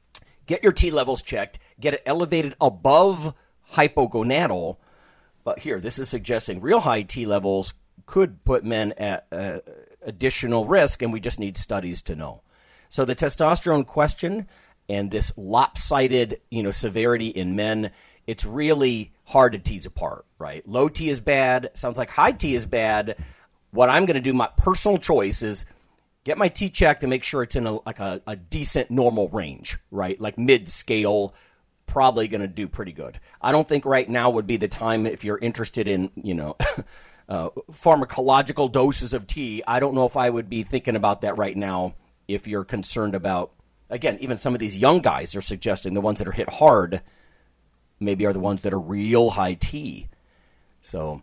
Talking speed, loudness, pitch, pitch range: 185 wpm, -23 LUFS, 115 Hz, 100-130 Hz